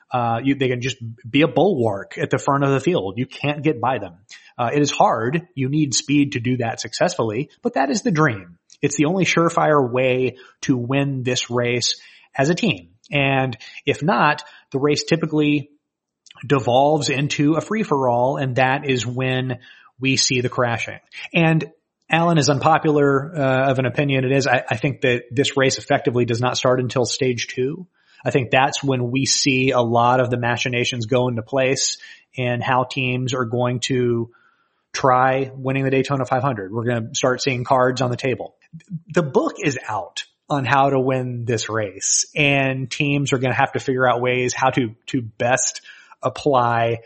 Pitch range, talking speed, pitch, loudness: 125-145 Hz, 190 wpm, 130 Hz, -20 LUFS